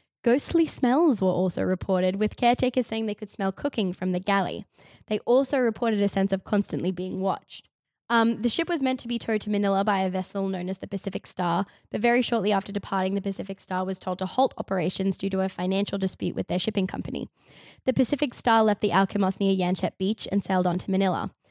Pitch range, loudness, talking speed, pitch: 190-230 Hz, -26 LUFS, 220 wpm, 200 Hz